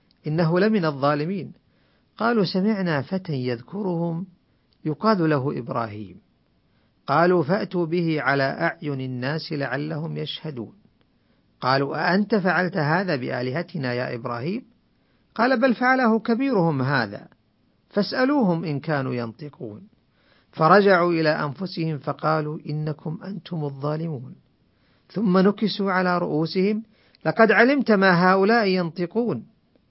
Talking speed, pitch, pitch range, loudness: 100 wpm, 170 Hz, 150-195 Hz, -22 LUFS